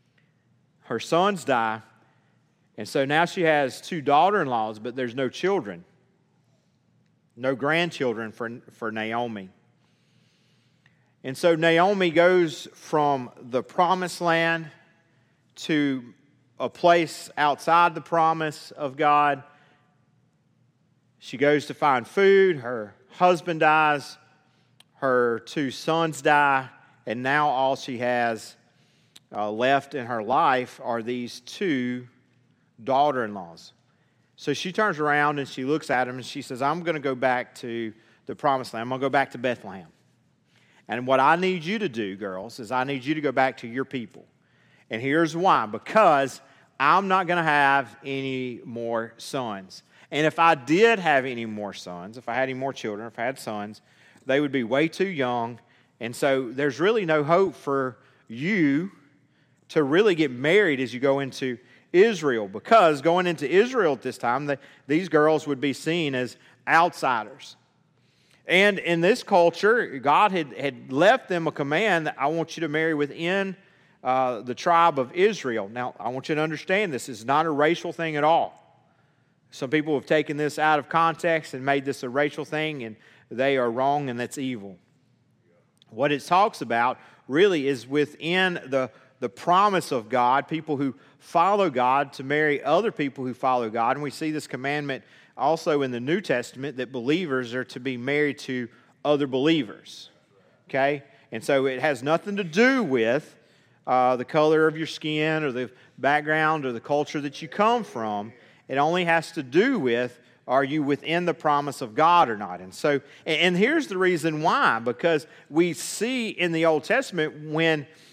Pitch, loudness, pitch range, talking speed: 145 Hz, -24 LUFS, 125-165 Hz, 170 wpm